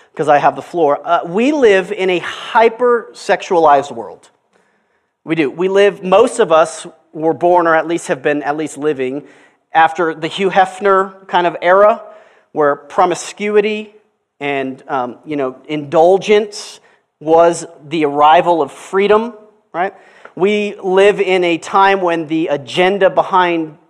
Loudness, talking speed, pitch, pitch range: -14 LUFS, 145 wpm, 175 Hz, 160-200 Hz